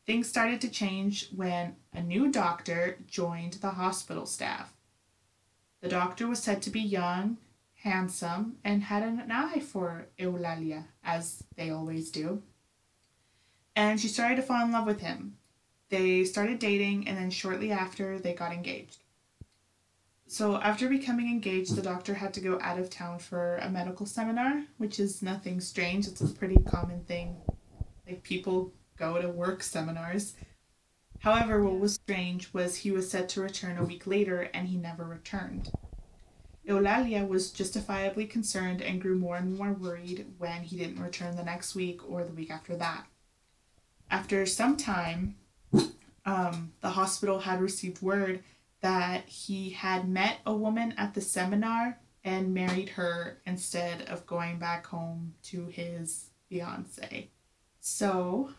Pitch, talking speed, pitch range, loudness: 185 Hz, 155 wpm, 175-205 Hz, -32 LUFS